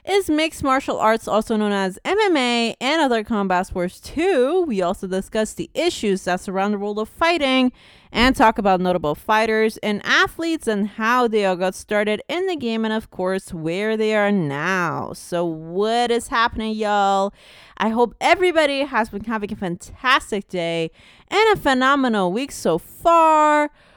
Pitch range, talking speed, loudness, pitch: 195-270 Hz, 170 wpm, -20 LUFS, 220 Hz